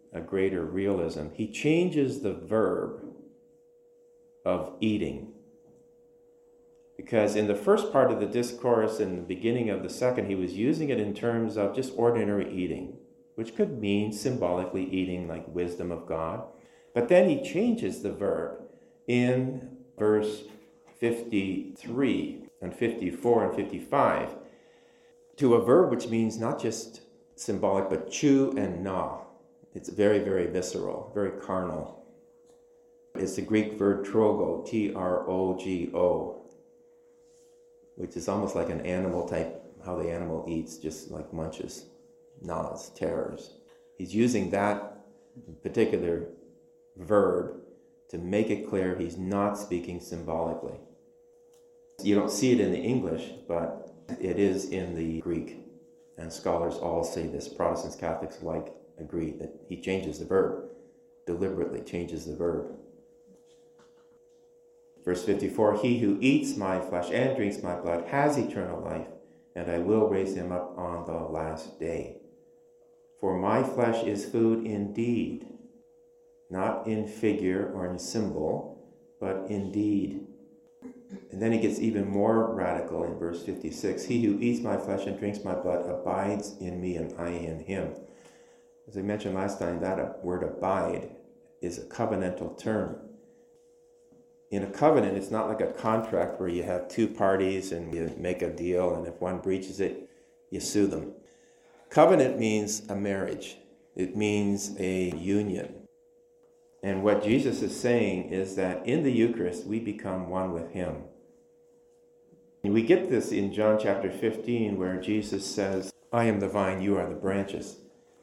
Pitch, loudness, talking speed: 105 Hz, -29 LUFS, 145 wpm